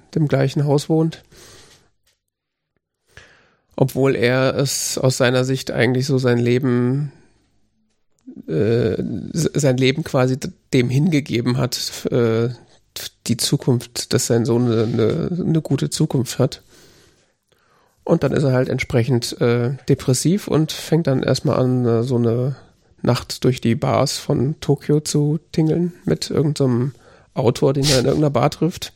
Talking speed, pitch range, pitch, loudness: 135 wpm, 120-145 Hz, 130 Hz, -19 LUFS